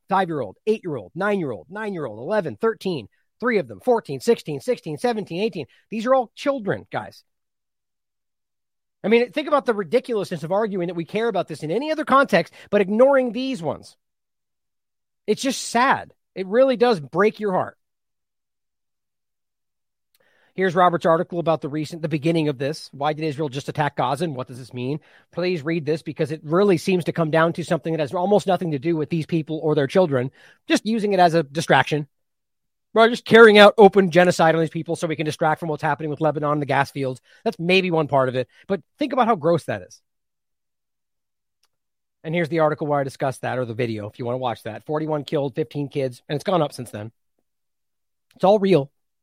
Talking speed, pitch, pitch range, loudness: 210 wpm, 165 Hz, 150-205 Hz, -21 LUFS